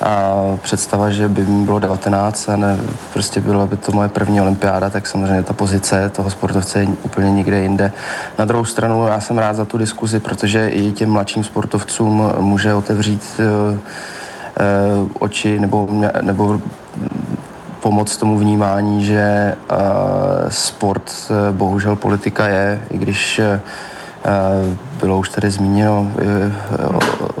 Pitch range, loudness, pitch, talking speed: 100-105 Hz, -16 LUFS, 100 Hz, 145 wpm